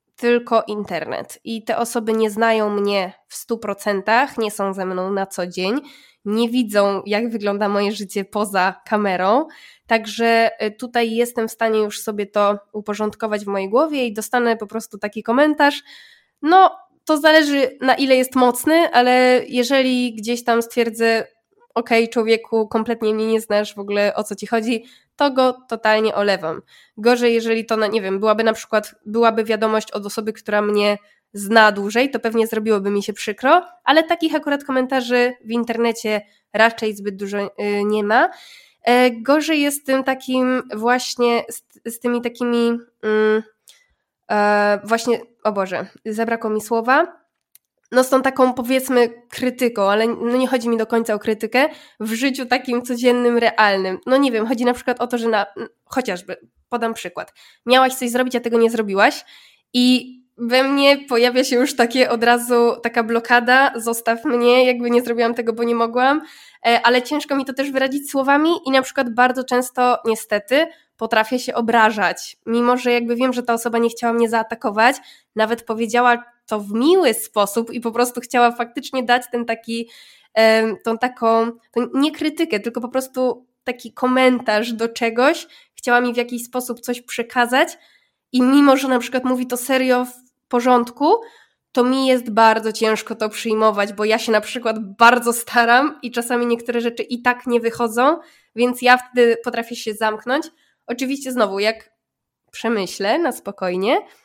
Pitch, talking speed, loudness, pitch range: 235 Hz, 165 wpm, -18 LUFS, 220-255 Hz